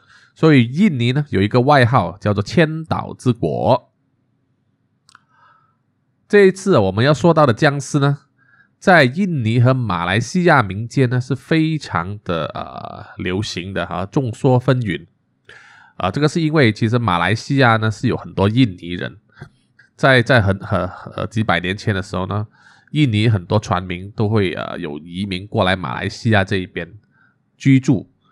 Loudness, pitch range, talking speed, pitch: -17 LUFS, 95-135 Hz, 235 characters per minute, 115 Hz